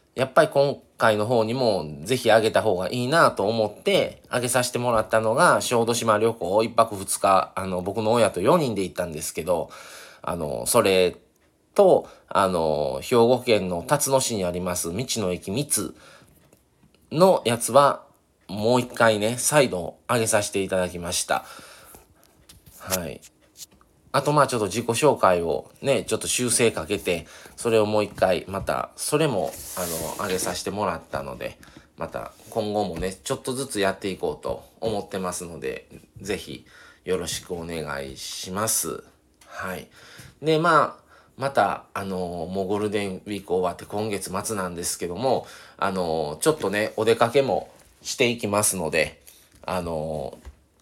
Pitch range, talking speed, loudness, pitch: 90-120 Hz, 295 characters per minute, -23 LUFS, 105 Hz